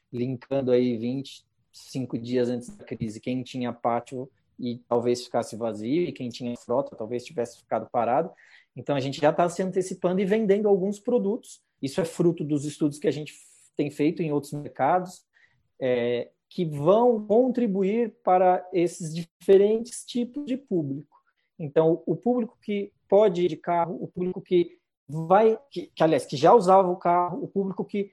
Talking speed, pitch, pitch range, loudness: 170 wpm, 170 Hz, 125-195 Hz, -25 LUFS